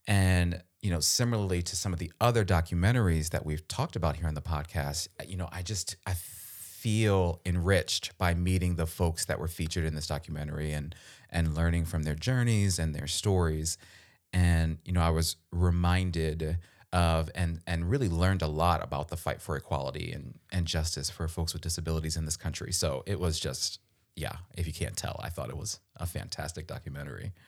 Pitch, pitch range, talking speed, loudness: 85 Hz, 80-95 Hz, 190 wpm, -31 LUFS